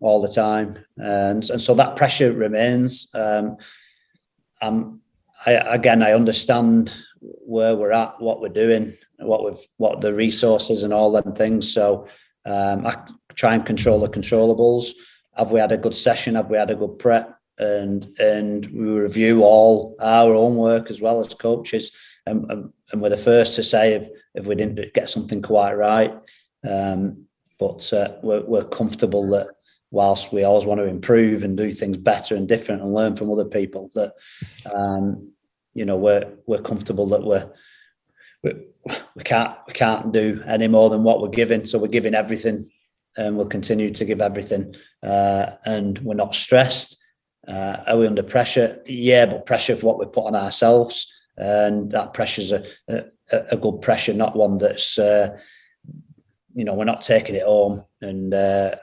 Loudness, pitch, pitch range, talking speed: -19 LUFS, 110 Hz, 100-115 Hz, 175 wpm